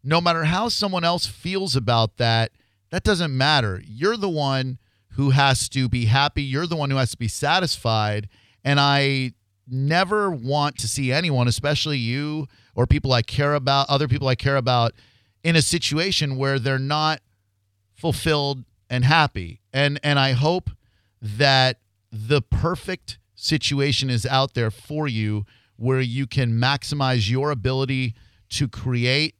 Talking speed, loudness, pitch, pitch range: 155 wpm, -21 LUFS, 130 Hz, 115-145 Hz